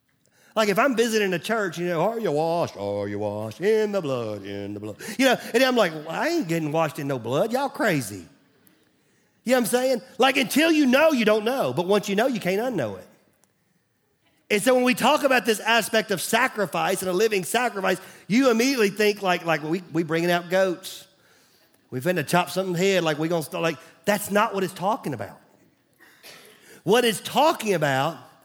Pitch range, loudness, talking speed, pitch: 165-230 Hz, -23 LUFS, 210 wpm, 190 Hz